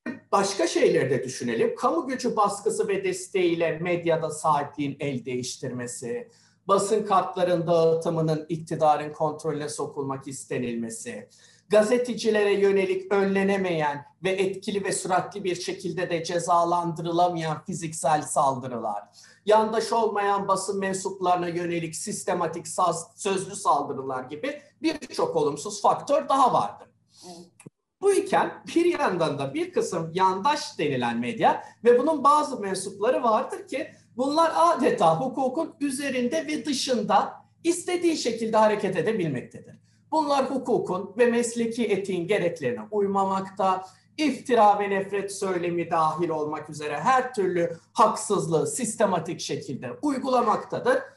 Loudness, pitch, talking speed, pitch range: -25 LUFS, 195 Hz, 110 wpm, 165-245 Hz